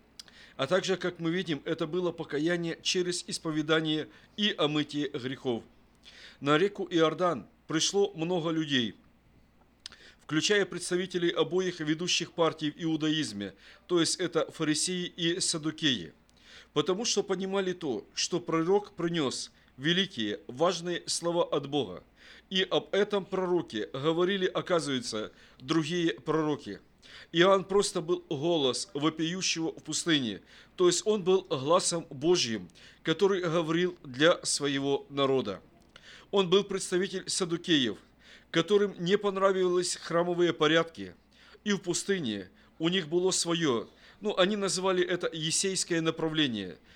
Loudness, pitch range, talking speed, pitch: -29 LUFS, 155-185 Hz, 120 wpm, 170 Hz